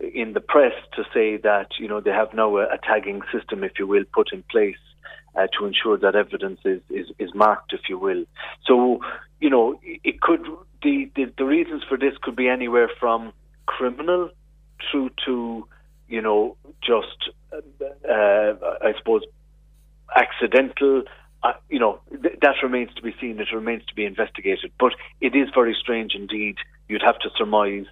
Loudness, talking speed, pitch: -22 LUFS, 175 wpm, 135 Hz